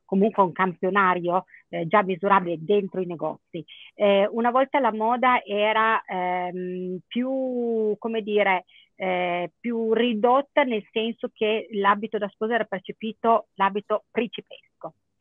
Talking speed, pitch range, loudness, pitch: 125 wpm, 185-230 Hz, -24 LUFS, 210 Hz